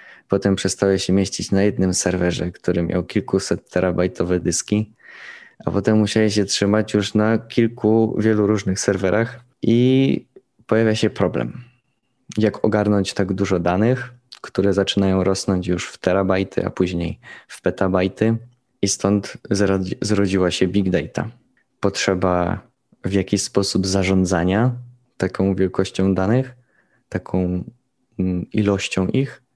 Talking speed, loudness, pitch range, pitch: 120 wpm, -20 LUFS, 95-110 Hz, 100 Hz